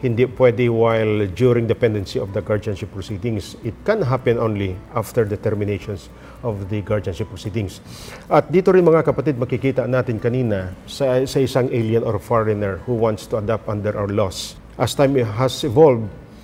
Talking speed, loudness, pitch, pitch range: 165 wpm, -20 LUFS, 115 Hz, 105-130 Hz